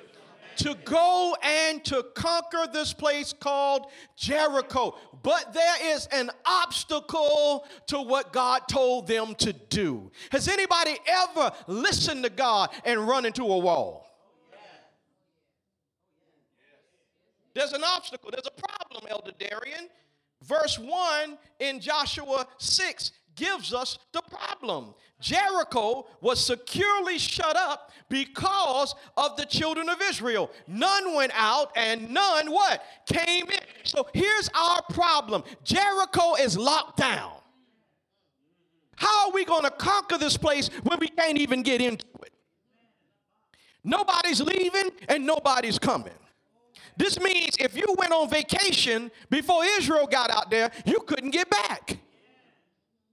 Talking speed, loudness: 125 wpm, -25 LUFS